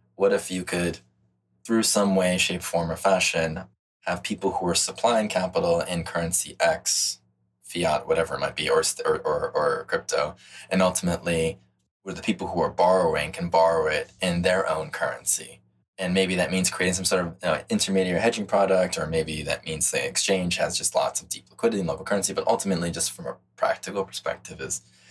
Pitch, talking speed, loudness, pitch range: 90 Hz, 190 wpm, -24 LUFS, 80-95 Hz